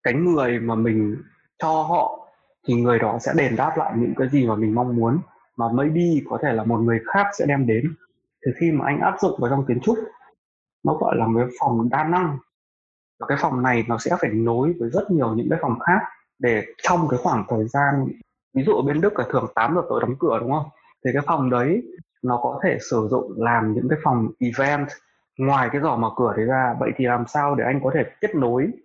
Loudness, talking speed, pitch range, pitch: -22 LUFS, 240 wpm, 115-155 Hz, 130 Hz